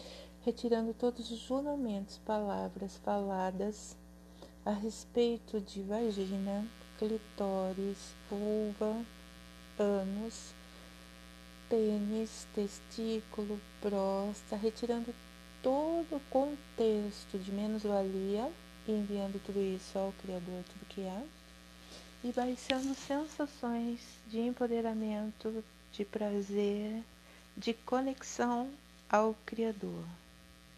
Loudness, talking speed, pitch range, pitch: -37 LUFS, 85 wpm, 190-230 Hz, 210 Hz